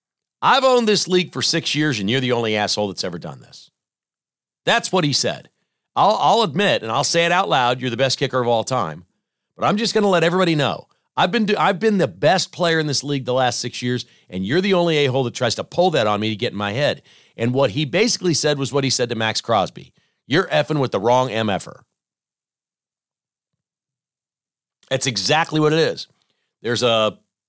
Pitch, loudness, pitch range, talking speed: 135 Hz, -19 LUFS, 120-170 Hz, 225 wpm